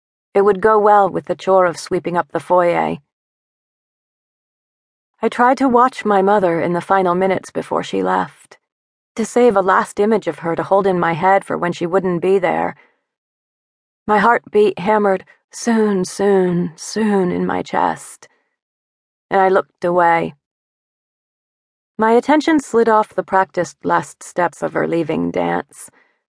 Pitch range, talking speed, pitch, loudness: 165-210 Hz, 155 wpm, 190 Hz, -16 LUFS